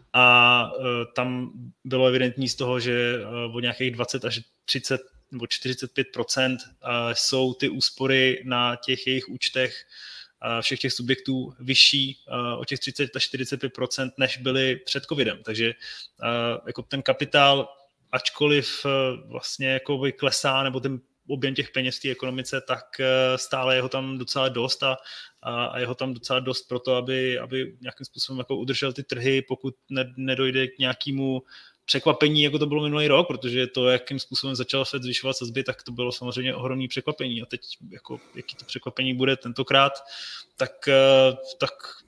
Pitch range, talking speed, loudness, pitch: 125-135 Hz, 170 wpm, -24 LUFS, 130 Hz